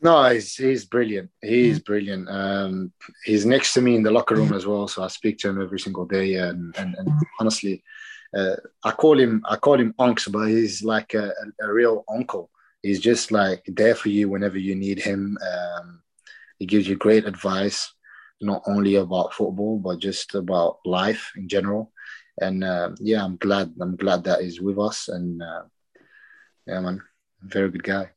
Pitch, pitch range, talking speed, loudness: 100 Hz, 95-110 Hz, 185 wpm, -22 LUFS